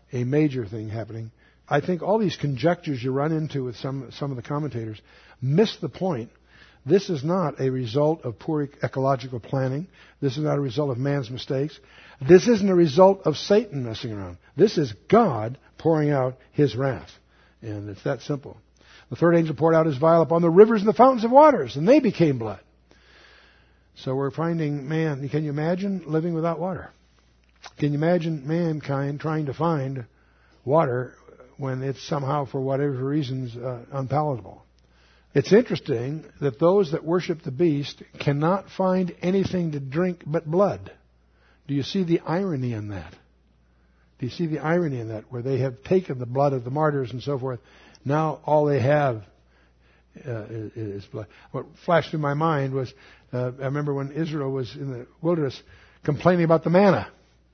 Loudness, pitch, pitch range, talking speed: -23 LUFS, 140 Hz, 125-165 Hz, 175 wpm